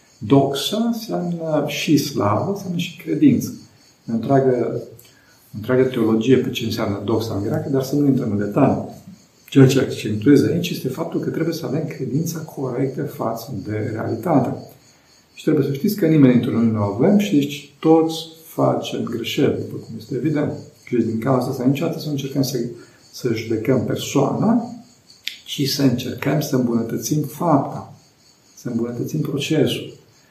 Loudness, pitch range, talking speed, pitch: -20 LUFS, 120-150 Hz, 155 wpm, 135 Hz